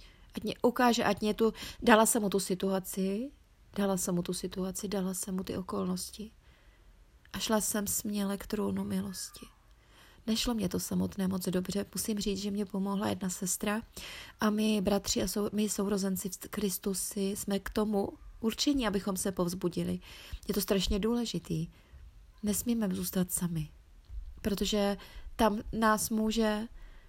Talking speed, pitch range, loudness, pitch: 150 wpm, 190-215 Hz, -32 LUFS, 200 Hz